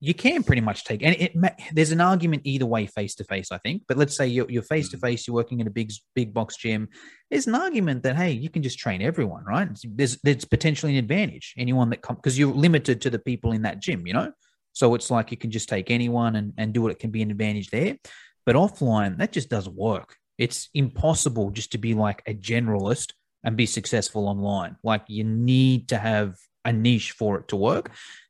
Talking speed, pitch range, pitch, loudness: 235 wpm, 110-140 Hz, 120 Hz, -24 LUFS